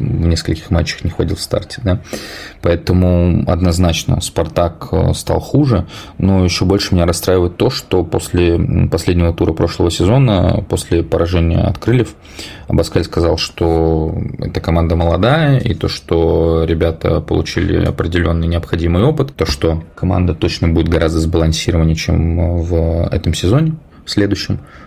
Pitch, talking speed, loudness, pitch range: 85 Hz, 135 wpm, -15 LUFS, 85-100 Hz